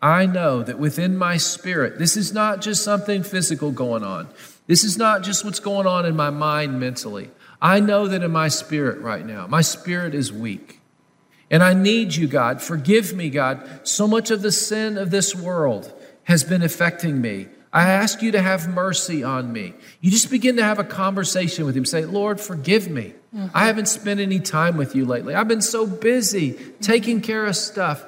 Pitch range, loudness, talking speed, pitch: 155-205 Hz, -20 LUFS, 200 wpm, 185 Hz